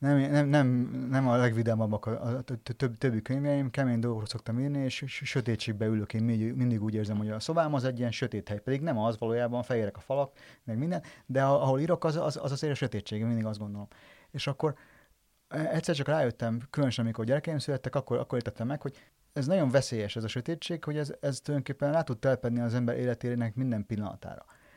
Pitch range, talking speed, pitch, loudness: 115-140 Hz, 205 wpm, 125 Hz, -31 LUFS